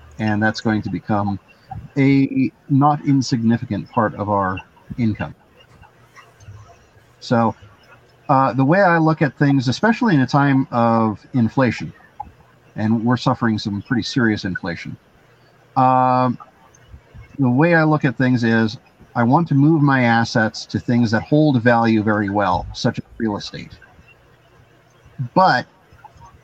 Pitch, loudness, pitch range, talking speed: 120 Hz, -18 LUFS, 110-135 Hz, 135 wpm